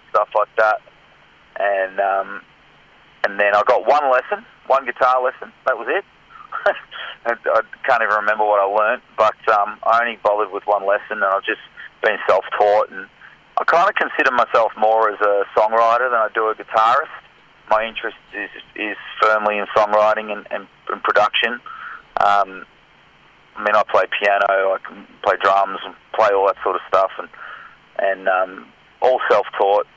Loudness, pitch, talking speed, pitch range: -18 LUFS, 105 Hz, 170 wpm, 100-110 Hz